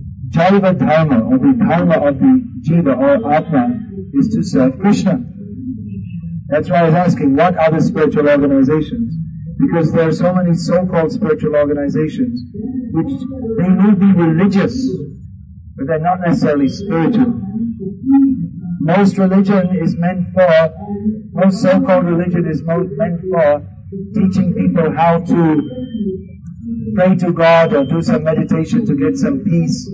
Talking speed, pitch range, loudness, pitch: 140 wpm, 165-215 Hz, -14 LUFS, 180 Hz